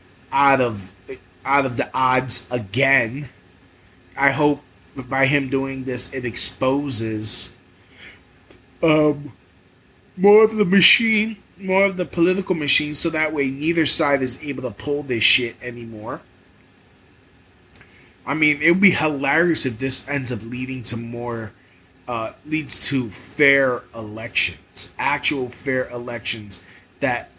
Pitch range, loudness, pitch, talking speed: 115-150 Hz, -19 LUFS, 130 Hz, 130 wpm